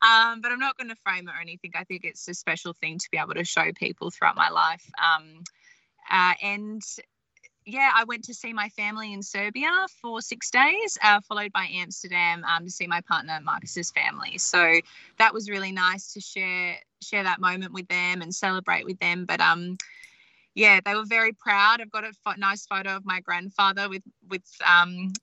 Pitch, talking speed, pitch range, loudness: 195 Hz, 205 wpm, 180-220 Hz, -24 LUFS